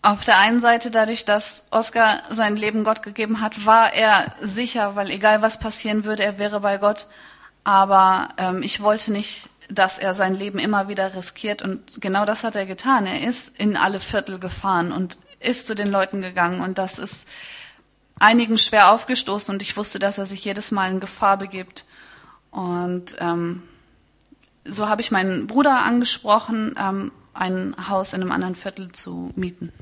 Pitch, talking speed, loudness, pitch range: 205 Hz, 175 wpm, -20 LUFS, 190-220 Hz